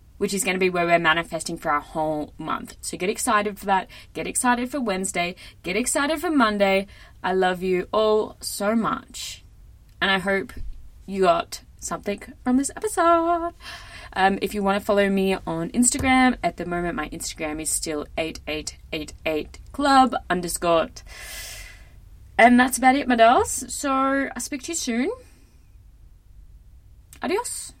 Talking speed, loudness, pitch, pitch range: 160 wpm, -23 LUFS, 200 Hz, 170-260 Hz